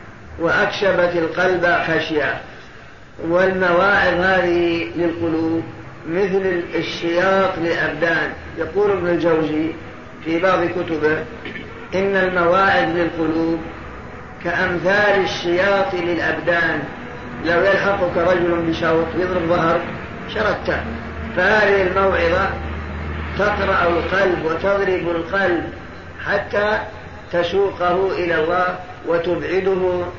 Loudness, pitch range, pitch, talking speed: -18 LUFS, 165-185 Hz, 175 Hz, 80 wpm